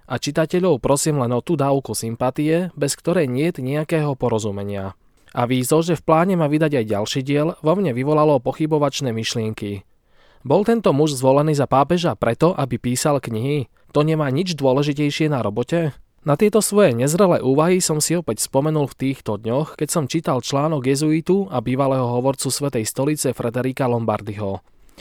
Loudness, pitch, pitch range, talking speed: -20 LUFS, 140 Hz, 125-155 Hz, 165 wpm